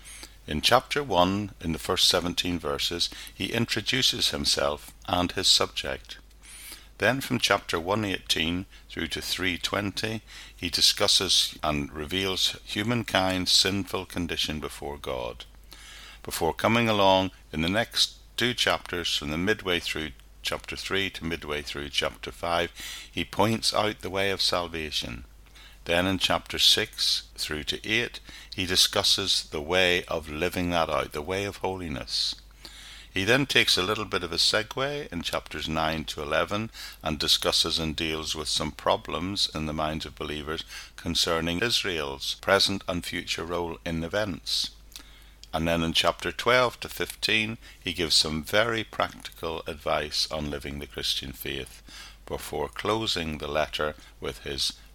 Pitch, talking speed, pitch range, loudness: 85 Hz, 145 wpm, 80-100 Hz, -26 LUFS